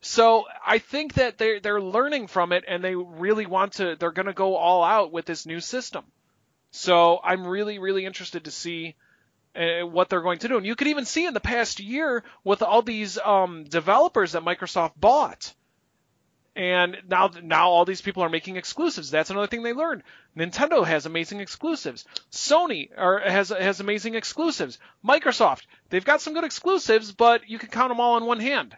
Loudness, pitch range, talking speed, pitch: -23 LUFS, 175-235 Hz, 190 wpm, 200 Hz